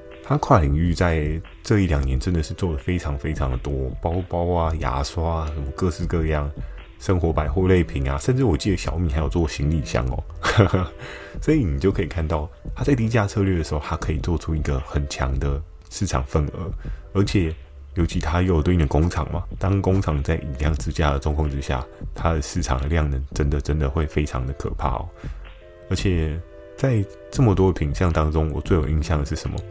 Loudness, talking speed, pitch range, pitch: -23 LUFS, 305 characters per minute, 75-90 Hz, 80 Hz